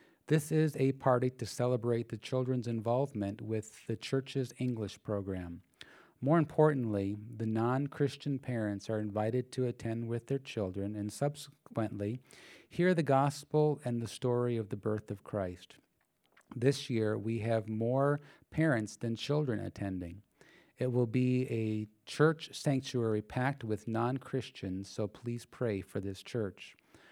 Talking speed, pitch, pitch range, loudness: 145 wpm, 120 Hz, 110-135 Hz, -34 LUFS